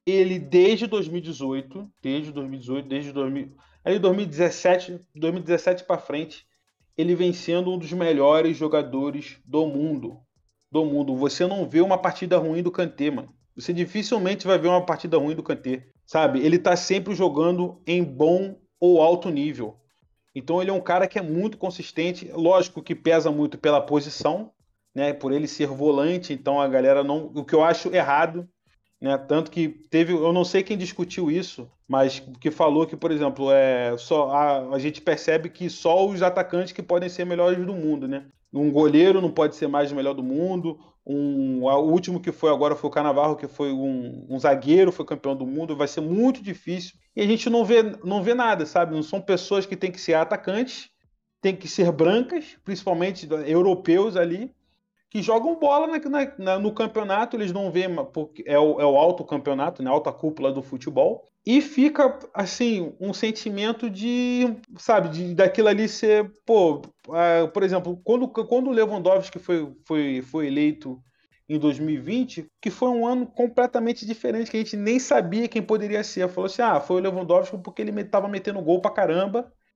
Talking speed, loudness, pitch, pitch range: 185 wpm, -23 LUFS, 175 Hz, 150-195 Hz